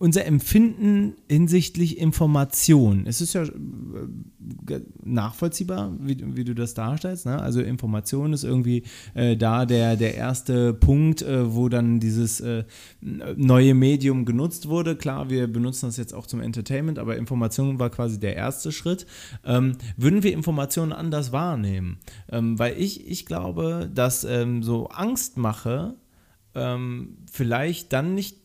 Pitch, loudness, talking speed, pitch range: 125 Hz, -23 LUFS, 145 wpm, 115-160 Hz